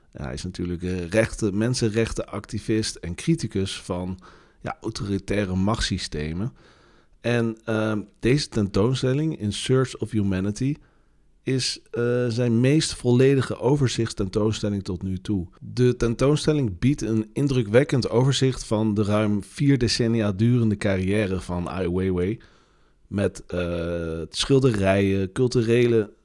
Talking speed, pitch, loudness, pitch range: 110 wpm, 110 Hz, -24 LUFS, 95-125 Hz